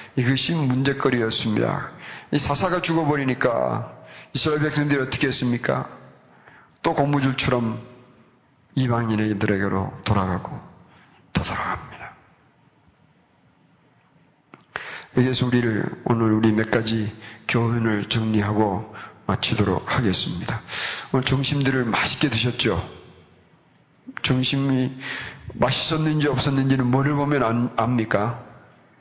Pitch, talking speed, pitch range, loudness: 125 Hz, 250 characters per minute, 110-140 Hz, -22 LUFS